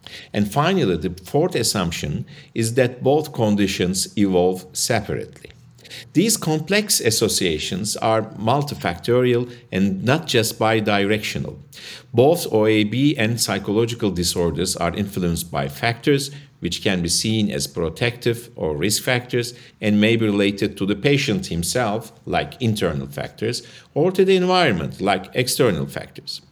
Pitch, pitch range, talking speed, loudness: 110 Hz, 100-125 Hz, 125 wpm, -20 LUFS